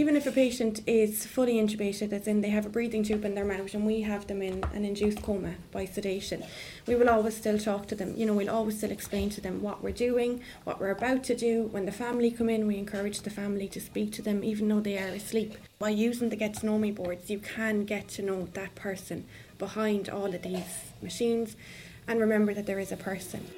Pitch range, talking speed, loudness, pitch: 200-220 Hz, 240 wpm, -30 LUFS, 210 Hz